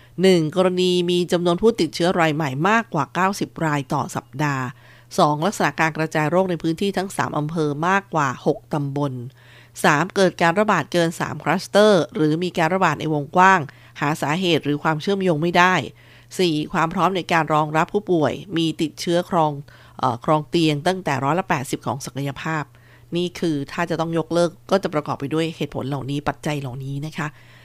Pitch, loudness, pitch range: 160 Hz, -21 LUFS, 145-180 Hz